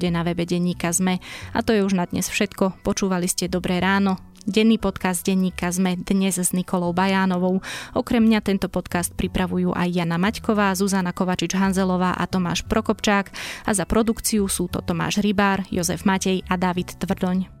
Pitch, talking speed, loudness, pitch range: 190 Hz, 165 wpm, -22 LUFS, 180-200 Hz